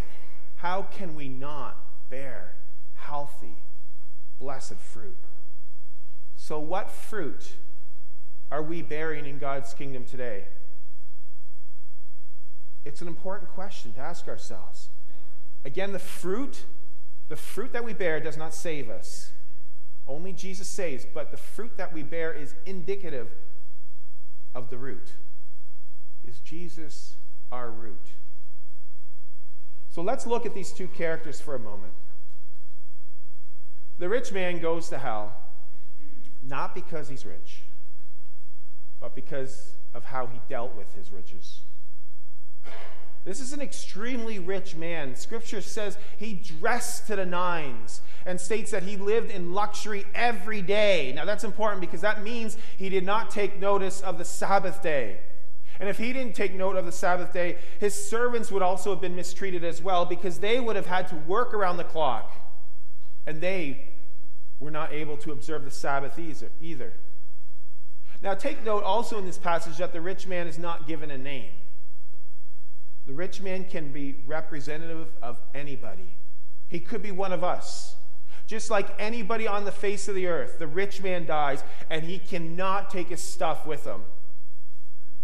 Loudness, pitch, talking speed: -32 LUFS, 155 Hz, 150 wpm